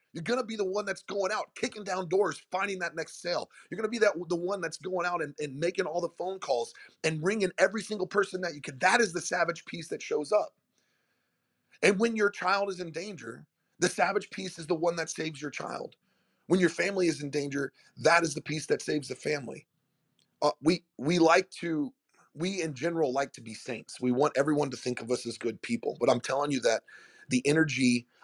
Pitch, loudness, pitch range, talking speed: 170 Hz, -30 LUFS, 150-195 Hz, 225 wpm